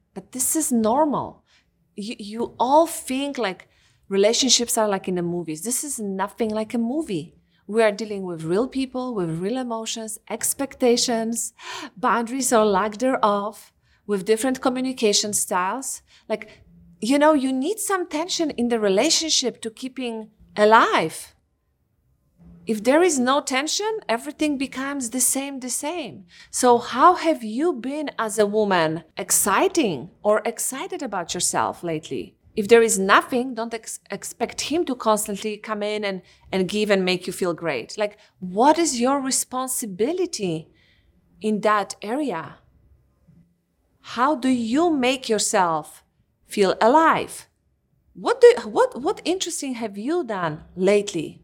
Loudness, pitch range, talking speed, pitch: -22 LUFS, 205-270 Hz, 145 wpm, 230 Hz